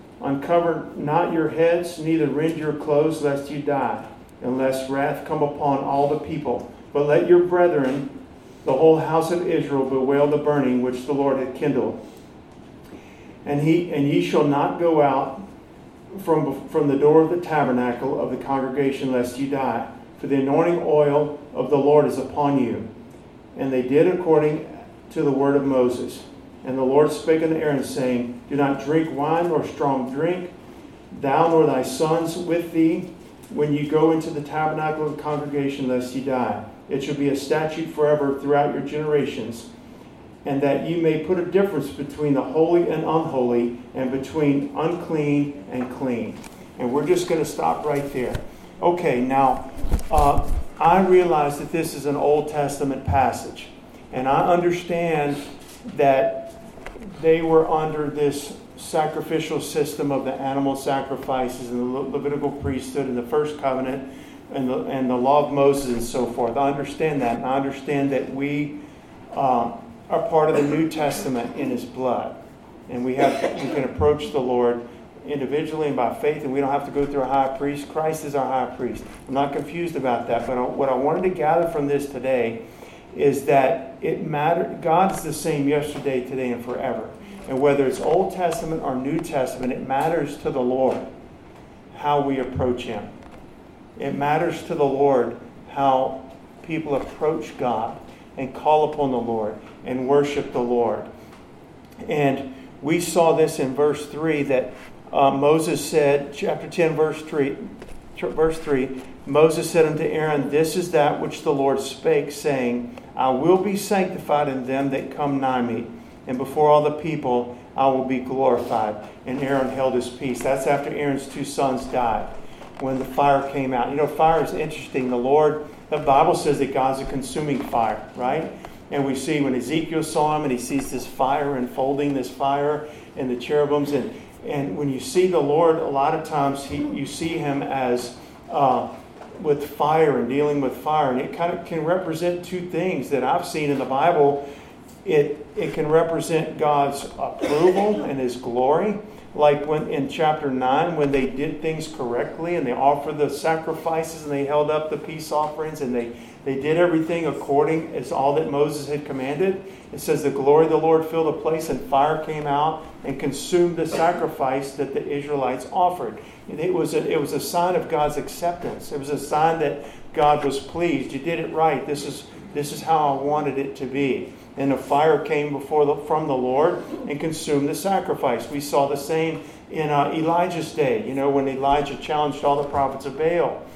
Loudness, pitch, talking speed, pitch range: -22 LUFS, 145 Hz, 180 wpm, 135-155 Hz